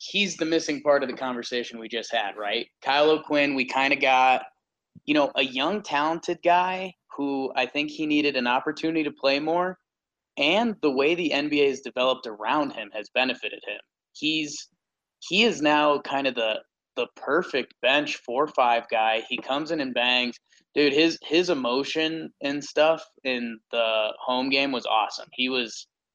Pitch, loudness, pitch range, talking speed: 145 Hz, -24 LUFS, 130-165 Hz, 175 wpm